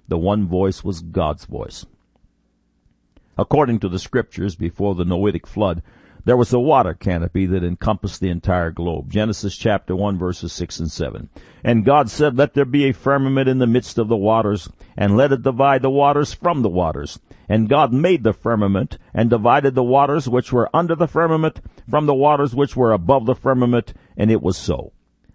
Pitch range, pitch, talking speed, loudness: 95-135 Hz, 110 Hz, 190 wpm, -18 LUFS